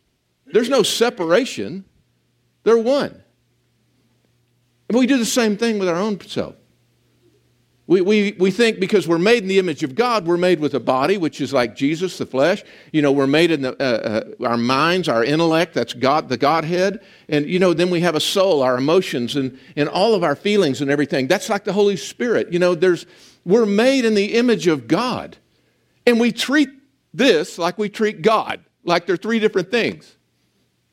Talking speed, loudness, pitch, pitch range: 190 wpm, -18 LUFS, 180 Hz, 145-215 Hz